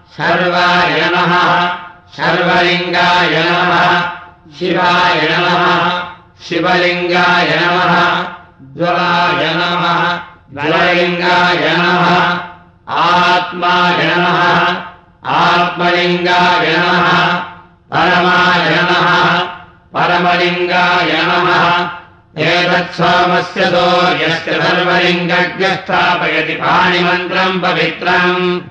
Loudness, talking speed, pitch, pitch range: -11 LUFS, 50 wpm, 175 Hz, 175-180 Hz